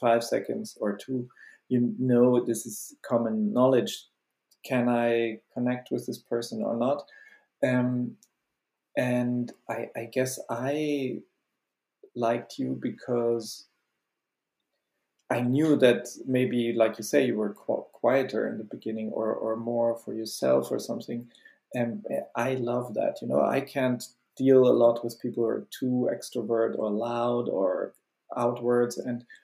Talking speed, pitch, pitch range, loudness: 140 wpm, 120 Hz, 115-125 Hz, -28 LUFS